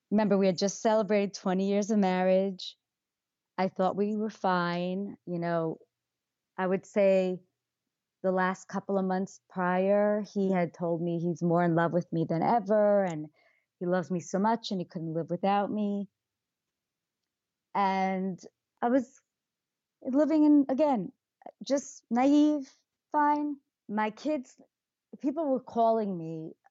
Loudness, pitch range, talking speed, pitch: -29 LUFS, 180-225 Hz, 145 wpm, 195 Hz